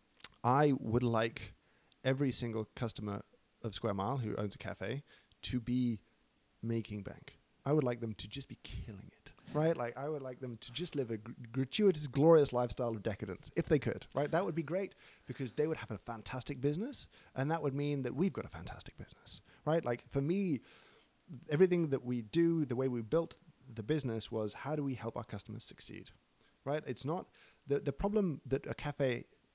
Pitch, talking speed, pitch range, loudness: 130 Hz, 200 wpm, 115-150 Hz, -36 LUFS